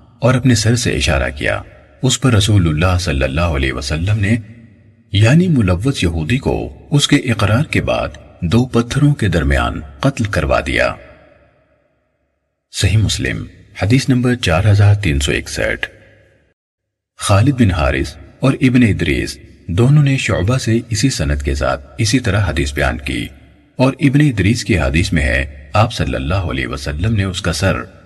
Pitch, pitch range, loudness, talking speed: 100 Hz, 80-120 Hz, -15 LUFS, 160 wpm